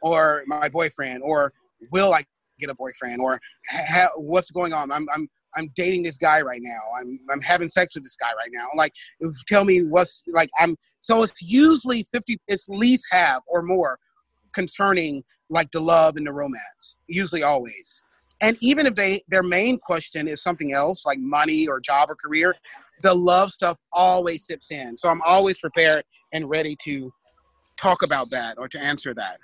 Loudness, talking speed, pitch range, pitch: -21 LUFS, 185 wpm, 150-190 Hz, 165 Hz